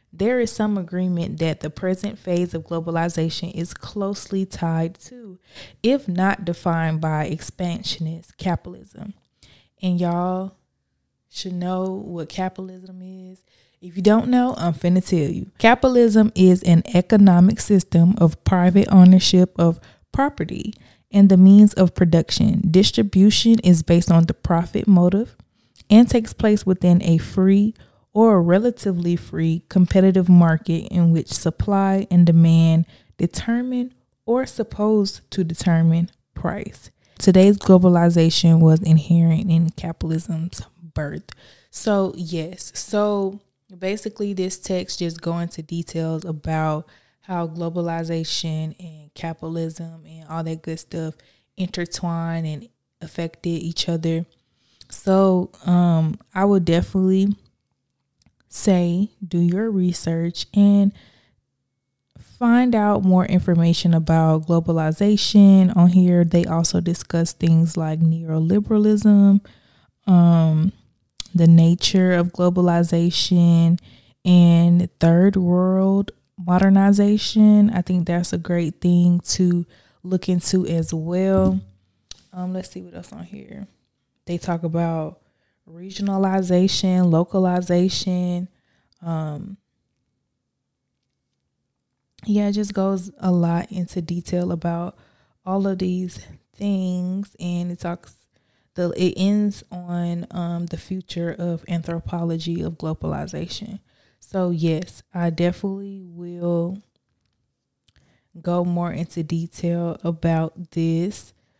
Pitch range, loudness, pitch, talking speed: 165-190 Hz, -19 LUFS, 175 Hz, 110 wpm